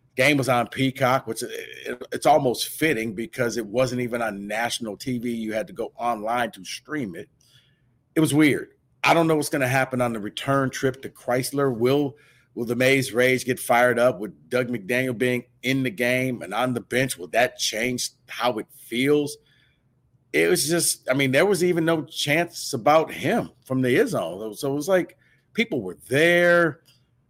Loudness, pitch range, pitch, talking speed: -23 LUFS, 120-145 Hz, 130 Hz, 190 wpm